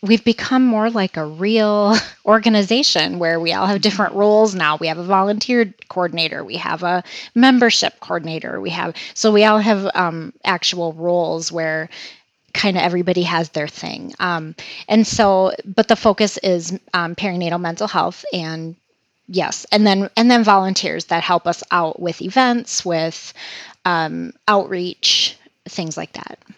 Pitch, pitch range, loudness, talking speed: 190 Hz, 170-215 Hz, -17 LUFS, 160 wpm